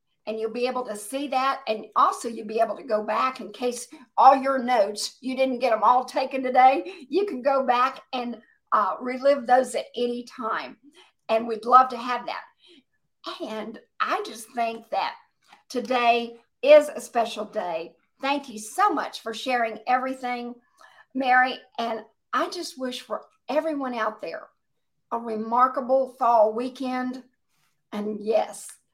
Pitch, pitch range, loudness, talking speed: 250 Hz, 225-270 Hz, -24 LUFS, 160 wpm